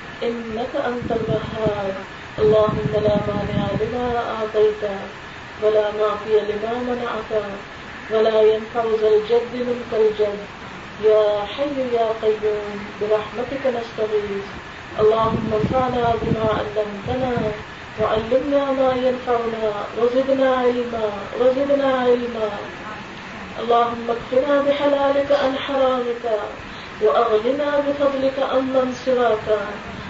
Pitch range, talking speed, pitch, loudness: 215-255 Hz, 90 wpm, 230 Hz, -20 LUFS